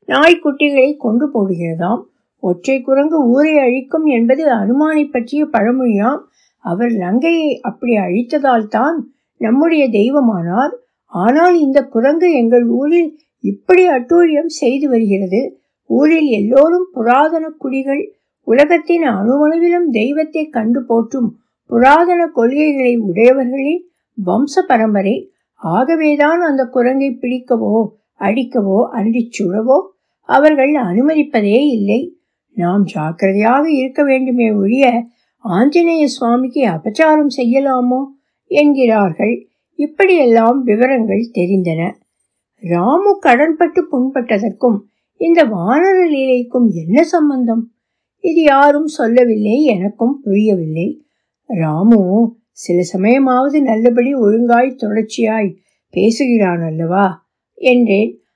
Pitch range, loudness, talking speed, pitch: 220-295 Hz, -13 LUFS, 80 wpm, 250 Hz